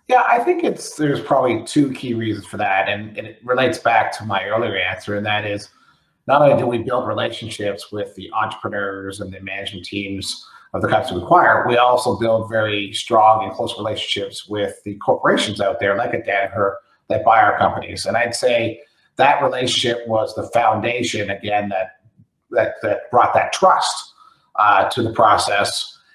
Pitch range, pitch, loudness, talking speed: 100-120 Hz, 110 Hz, -18 LUFS, 185 wpm